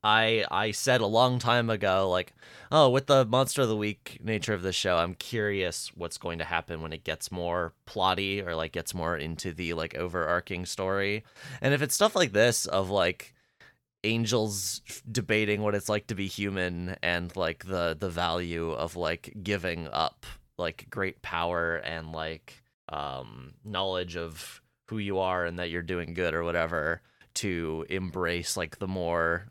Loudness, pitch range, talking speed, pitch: -29 LUFS, 85-105 Hz, 180 wpm, 95 Hz